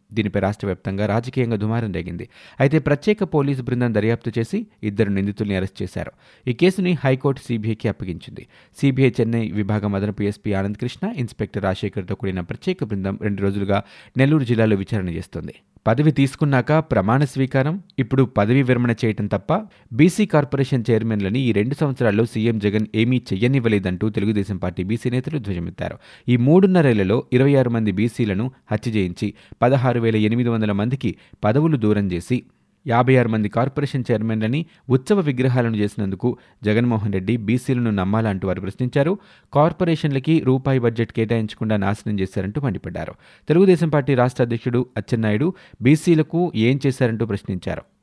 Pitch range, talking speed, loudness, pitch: 105-135 Hz, 135 wpm, -20 LUFS, 115 Hz